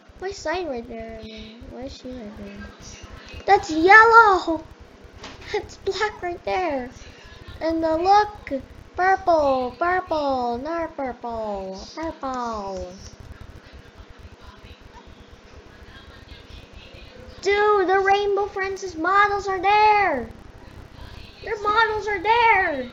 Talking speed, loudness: 85 wpm, -20 LUFS